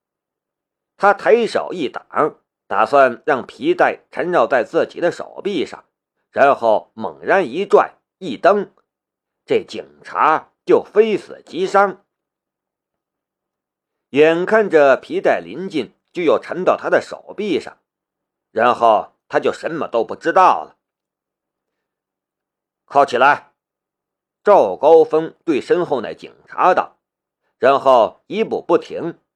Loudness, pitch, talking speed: -17 LUFS, 360 Hz, 165 characters per minute